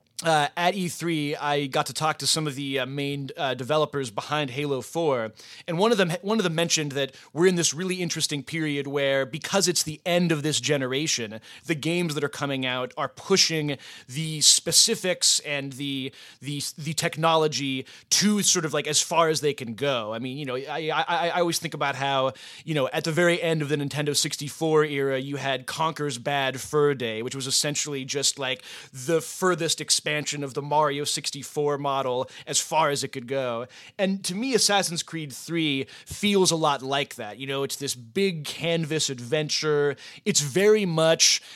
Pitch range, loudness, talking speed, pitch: 135-165 Hz, -24 LUFS, 195 wpm, 150 Hz